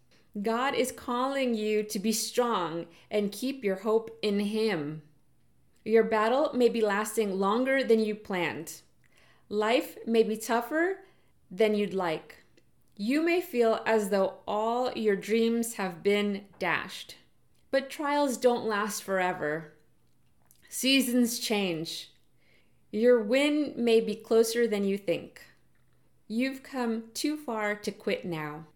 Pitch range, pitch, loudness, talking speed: 195-240 Hz, 220 Hz, -28 LUFS, 130 wpm